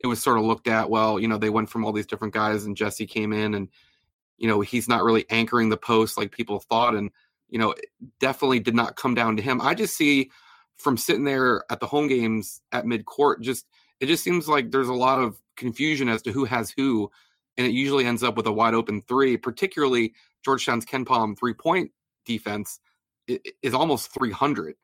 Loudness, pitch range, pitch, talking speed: -24 LUFS, 110-130 Hz, 115 Hz, 220 wpm